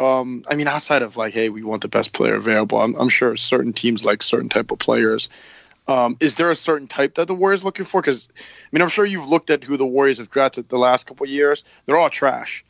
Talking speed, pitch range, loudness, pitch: 265 wpm, 120-160 Hz, -19 LUFS, 135 Hz